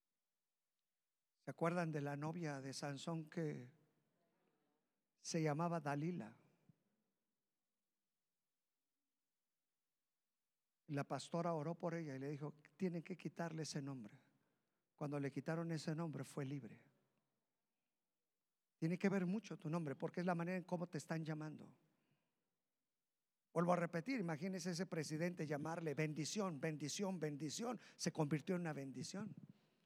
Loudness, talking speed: -45 LUFS, 125 wpm